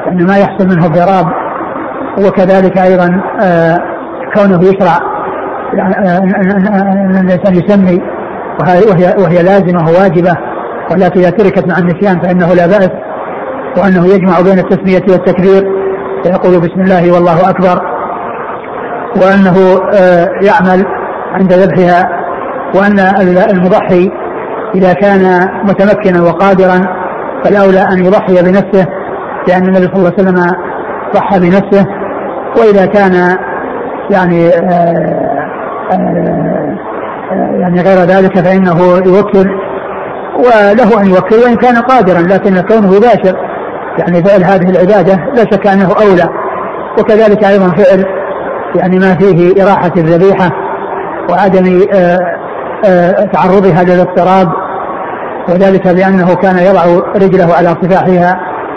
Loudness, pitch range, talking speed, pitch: -8 LUFS, 180-195 Hz, 100 wpm, 190 Hz